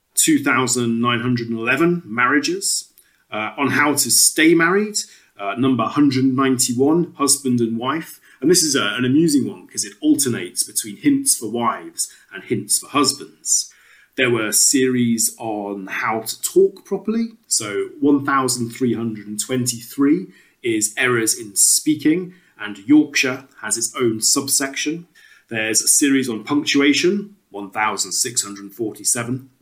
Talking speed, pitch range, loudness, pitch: 120 wpm, 115-180 Hz, -18 LUFS, 135 Hz